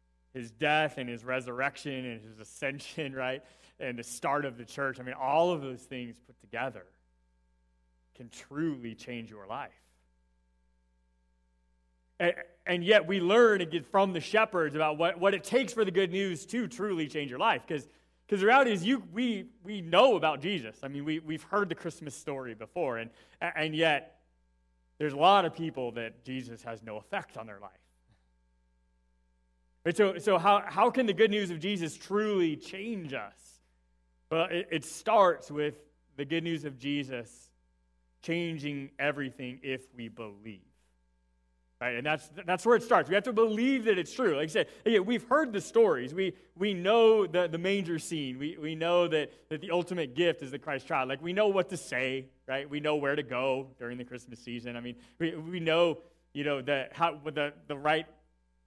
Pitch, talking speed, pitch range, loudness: 145 Hz, 185 wpm, 115-175 Hz, -30 LUFS